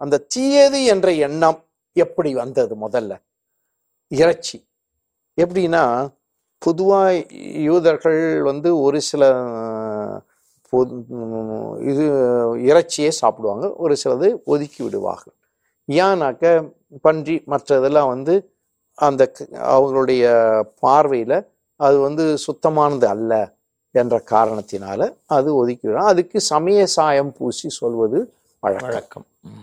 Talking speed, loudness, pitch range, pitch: 85 wpm, -18 LUFS, 130-175 Hz, 150 Hz